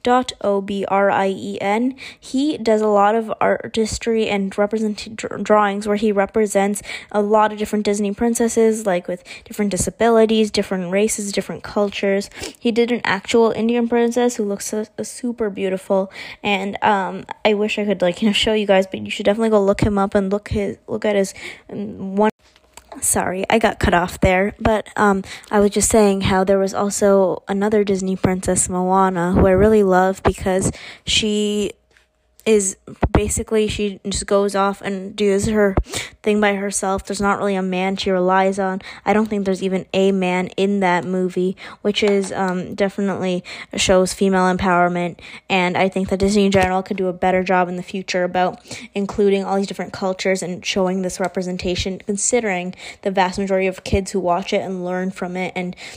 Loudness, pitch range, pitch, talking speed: -19 LUFS, 190-210 Hz, 200 Hz, 185 wpm